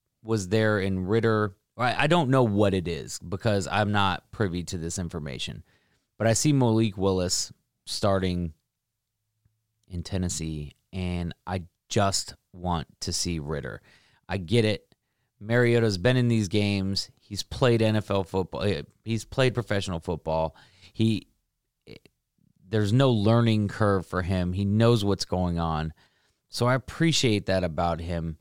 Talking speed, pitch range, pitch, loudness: 140 wpm, 90-115 Hz, 100 Hz, -26 LUFS